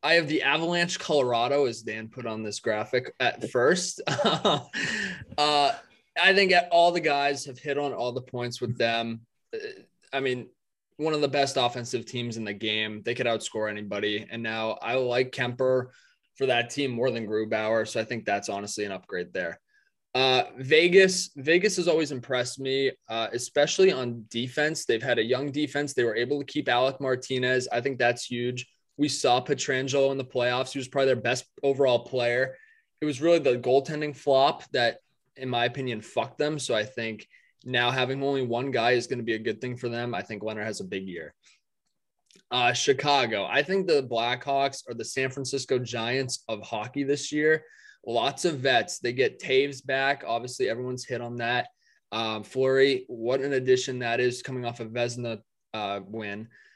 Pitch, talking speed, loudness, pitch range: 130 Hz, 190 wpm, -26 LUFS, 120-140 Hz